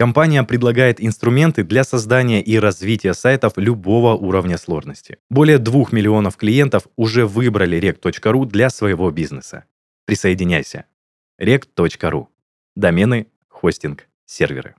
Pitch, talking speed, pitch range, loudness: 110 Hz, 105 wpm, 95-125 Hz, -16 LUFS